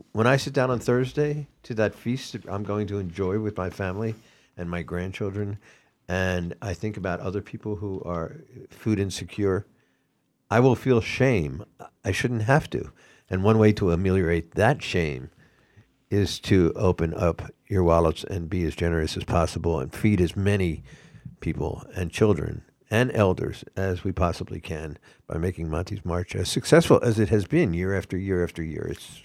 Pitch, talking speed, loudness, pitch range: 100 Hz, 175 wpm, -25 LUFS, 90-110 Hz